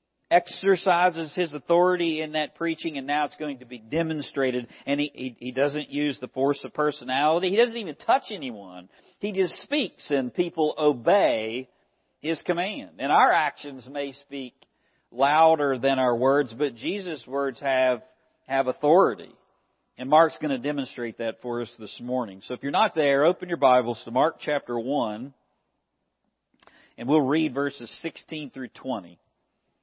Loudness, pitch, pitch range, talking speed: -25 LUFS, 145 Hz, 130-165 Hz, 160 wpm